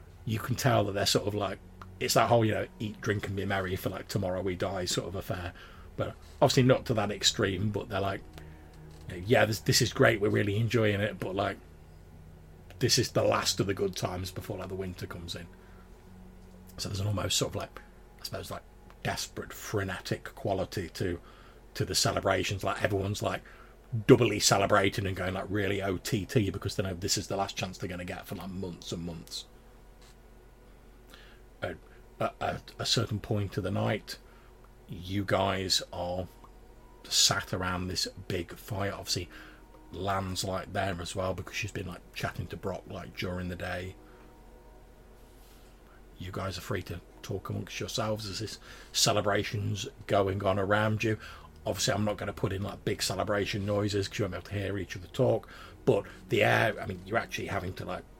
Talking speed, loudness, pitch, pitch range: 185 wpm, -30 LUFS, 100 Hz, 90-105 Hz